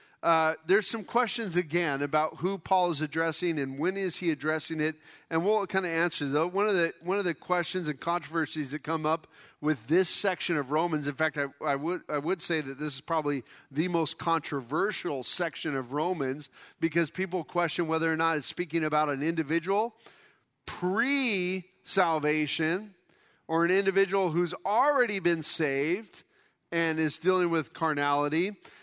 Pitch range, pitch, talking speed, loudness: 155-180 Hz, 165 Hz, 170 wpm, -29 LUFS